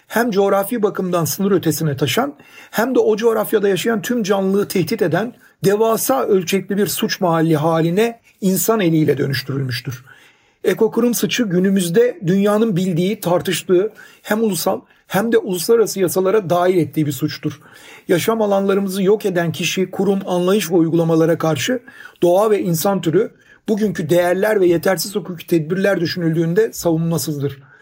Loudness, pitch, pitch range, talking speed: -17 LUFS, 190 Hz, 170-215 Hz, 135 wpm